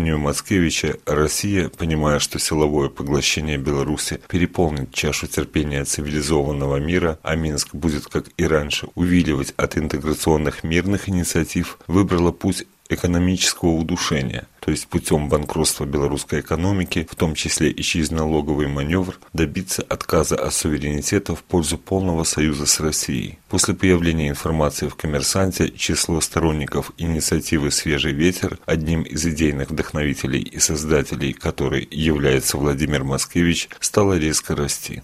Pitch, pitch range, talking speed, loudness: 80 Hz, 75-85 Hz, 125 wpm, -20 LUFS